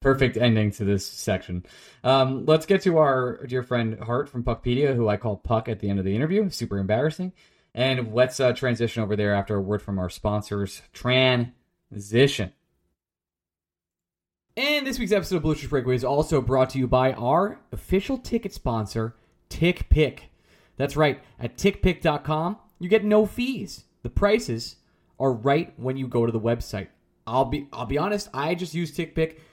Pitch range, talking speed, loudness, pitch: 110-160 Hz, 175 wpm, -24 LUFS, 130 Hz